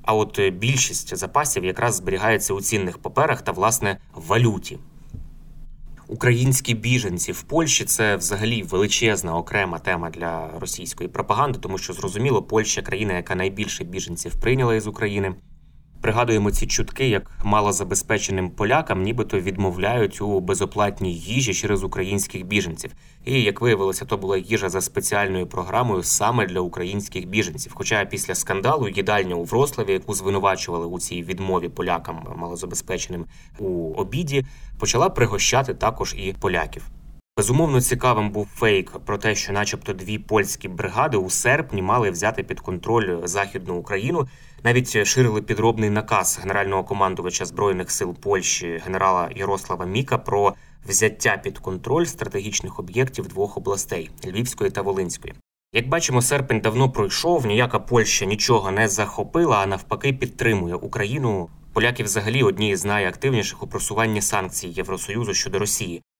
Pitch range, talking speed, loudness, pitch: 95-120 Hz, 135 wpm, -22 LUFS, 105 Hz